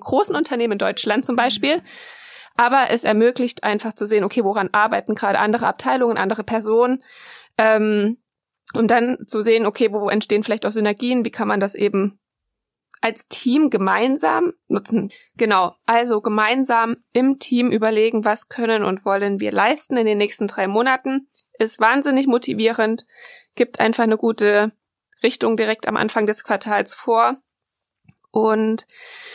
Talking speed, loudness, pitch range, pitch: 150 wpm, -19 LUFS, 215-245 Hz, 225 Hz